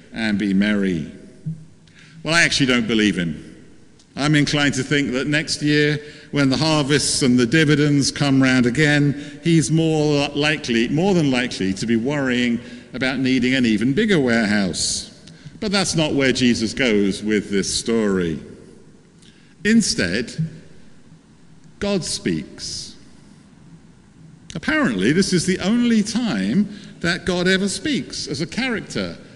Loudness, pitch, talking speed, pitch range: -19 LUFS, 145 Hz, 135 wpm, 120-160 Hz